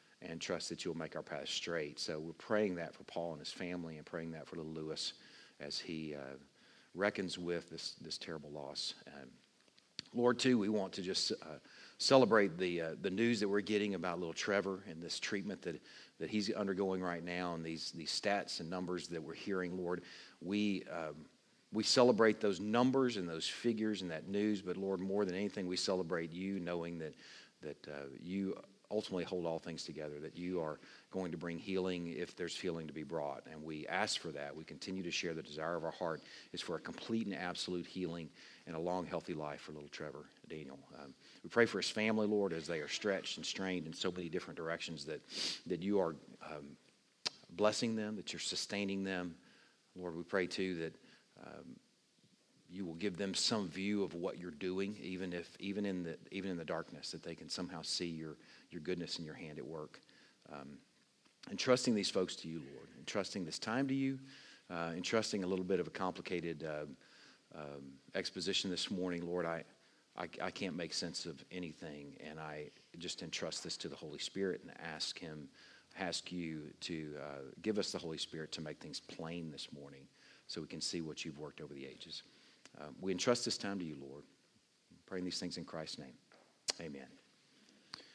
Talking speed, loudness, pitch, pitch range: 205 wpm, -40 LUFS, 90 Hz, 80-100 Hz